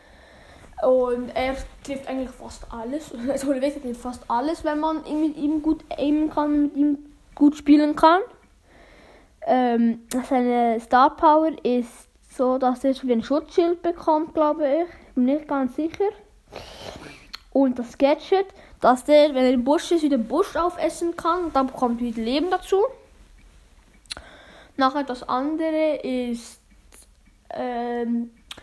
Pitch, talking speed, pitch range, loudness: 285 Hz, 140 wpm, 255-315 Hz, -22 LUFS